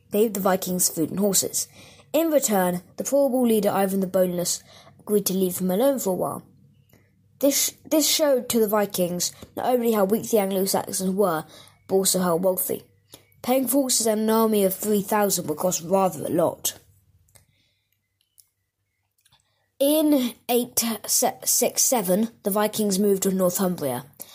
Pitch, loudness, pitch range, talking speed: 195 Hz, -22 LUFS, 175-225 Hz, 150 wpm